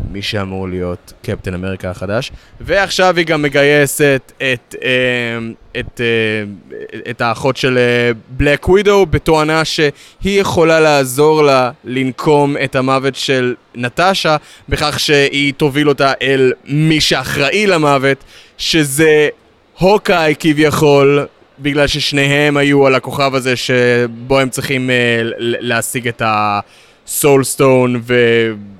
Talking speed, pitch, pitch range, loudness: 110 wpm, 135 Hz, 120-150 Hz, -13 LUFS